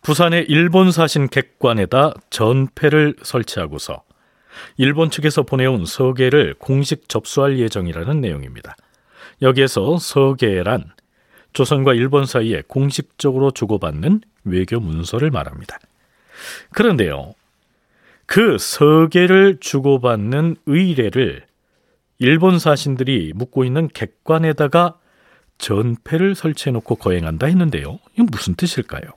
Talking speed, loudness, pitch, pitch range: 270 characters per minute, -16 LUFS, 140 Hz, 120-160 Hz